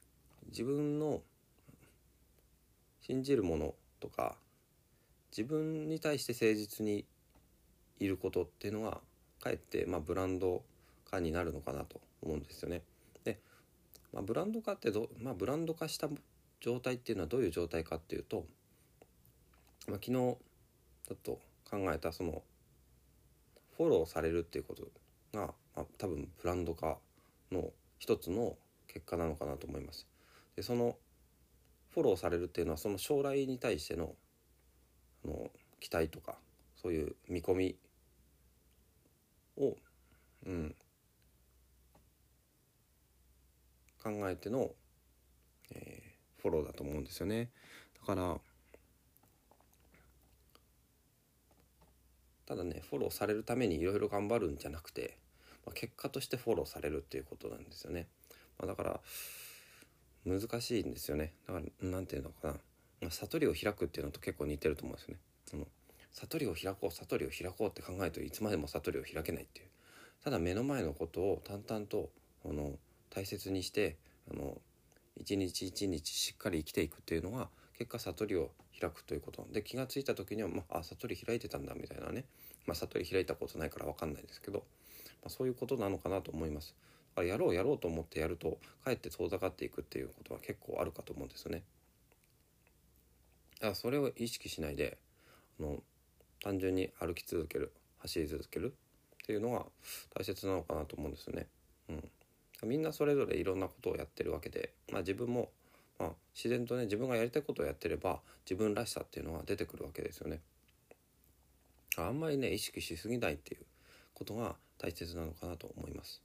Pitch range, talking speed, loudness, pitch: 70-110 Hz, 305 characters per minute, -39 LUFS, 85 Hz